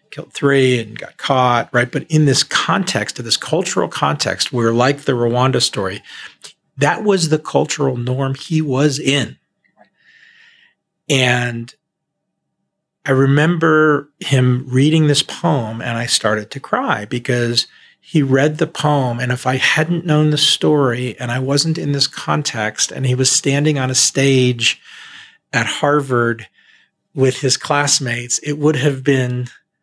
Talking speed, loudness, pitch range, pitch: 145 wpm, -16 LUFS, 125-150 Hz, 135 Hz